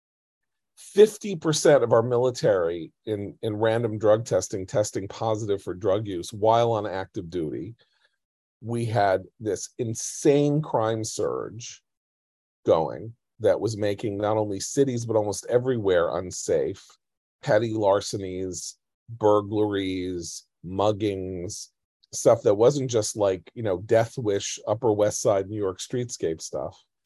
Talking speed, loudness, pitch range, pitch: 120 wpm, -25 LUFS, 100-120 Hz, 110 Hz